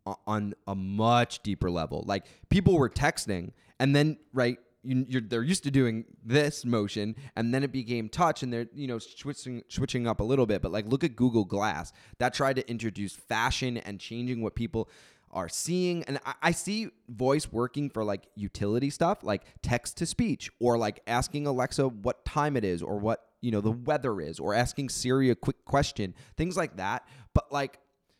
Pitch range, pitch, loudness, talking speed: 110-135 Hz, 120 Hz, -30 LUFS, 195 wpm